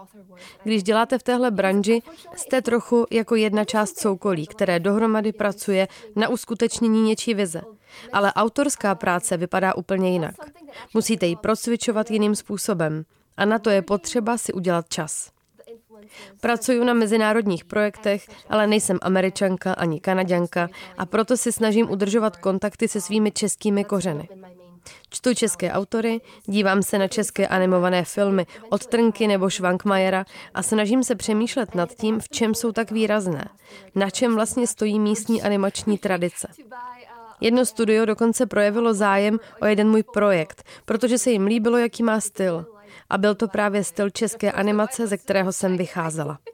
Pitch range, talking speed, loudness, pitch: 190-225 Hz, 145 wpm, -22 LUFS, 210 Hz